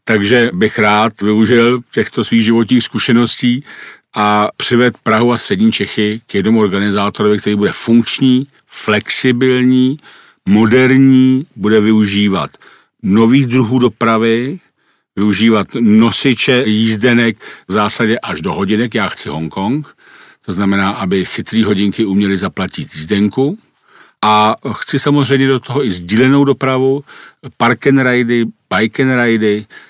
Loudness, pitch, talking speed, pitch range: -12 LUFS, 115 Hz, 120 wpm, 105-130 Hz